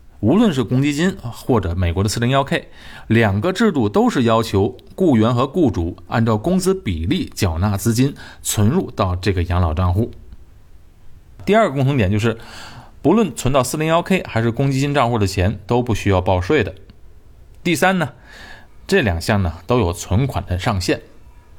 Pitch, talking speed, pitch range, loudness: 110 Hz, 240 characters per minute, 95-130 Hz, -18 LUFS